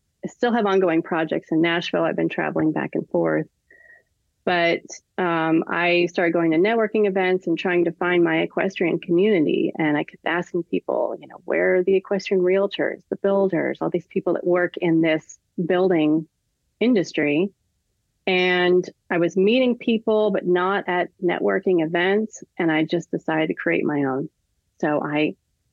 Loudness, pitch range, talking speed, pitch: -21 LUFS, 160-190 Hz, 165 wpm, 175 Hz